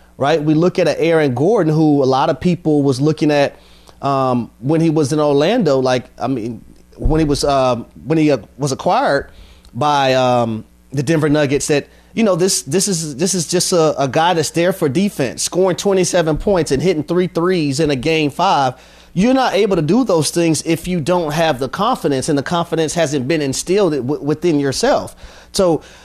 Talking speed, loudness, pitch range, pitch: 205 wpm, -16 LUFS, 135-170 Hz, 155 Hz